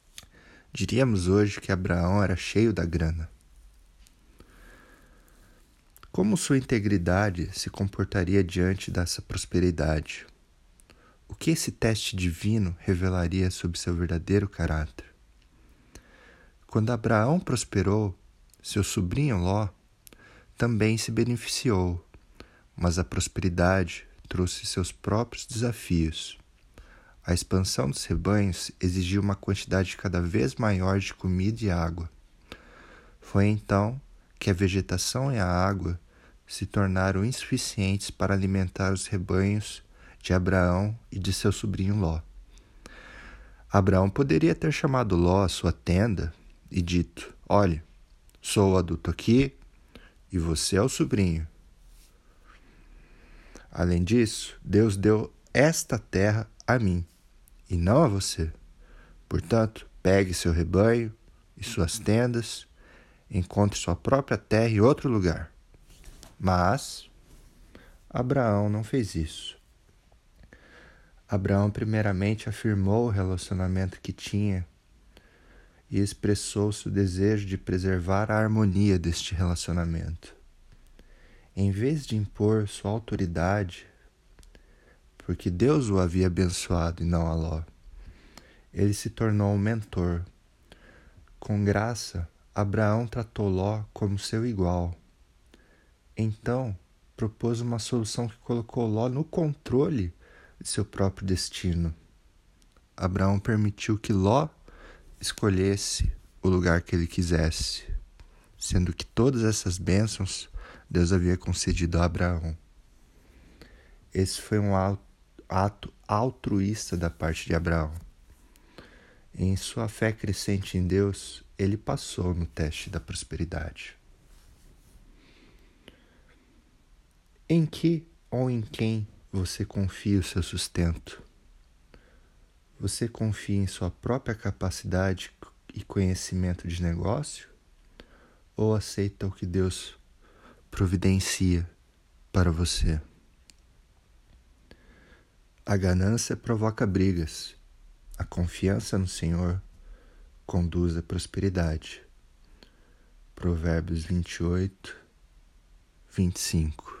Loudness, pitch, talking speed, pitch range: -27 LUFS, 95 Hz, 105 wpm, 85-105 Hz